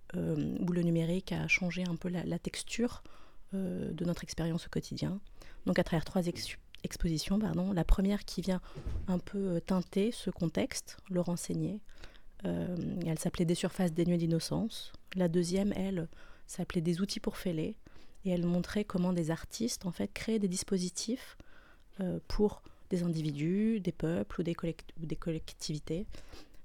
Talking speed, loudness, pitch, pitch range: 160 wpm, -35 LUFS, 180 Hz, 170-195 Hz